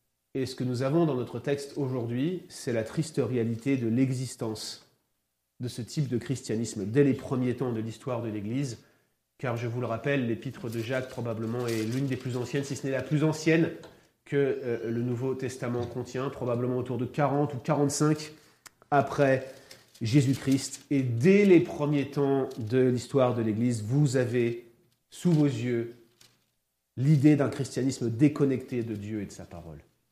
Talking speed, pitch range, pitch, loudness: 170 wpm, 115-140 Hz, 130 Hz, -28 LUFS